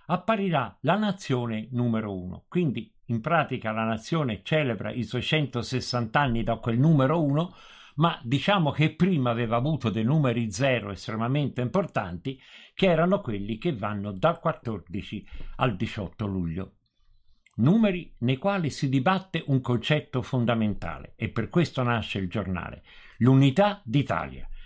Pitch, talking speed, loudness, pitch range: 125 Hz, 135 wpm, -26 LUFS, 110-155 Hz